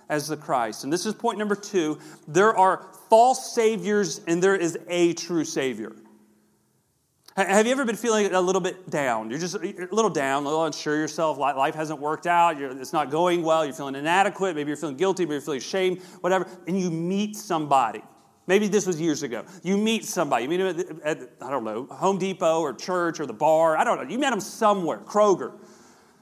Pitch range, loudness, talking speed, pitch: 155-195 Hz, -24 LUFS, 210 wpm, 175 Hz